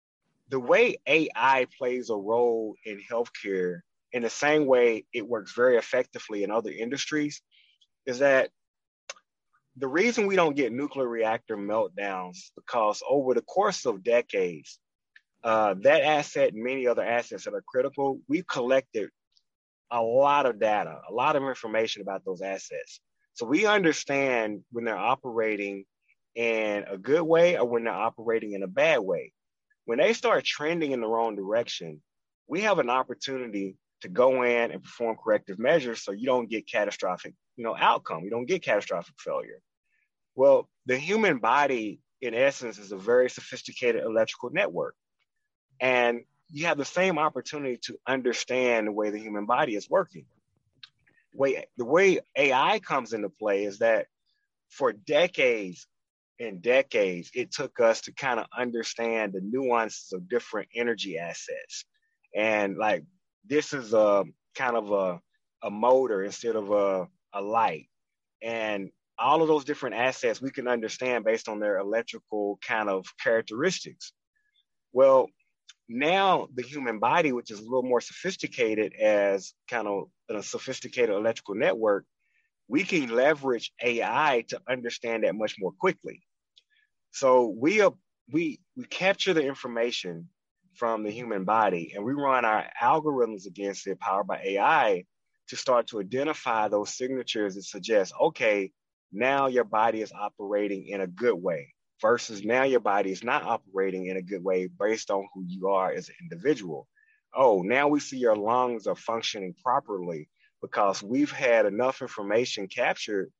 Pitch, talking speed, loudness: 125 Hz, 155 wpm, -27 LUFS